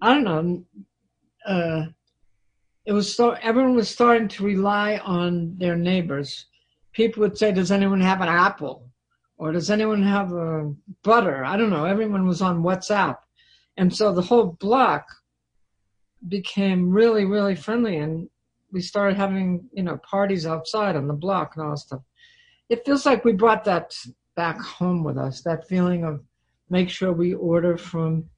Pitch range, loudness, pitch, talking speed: 160-210 Hz, -22 LUFS, 185 Hz, 165 wpm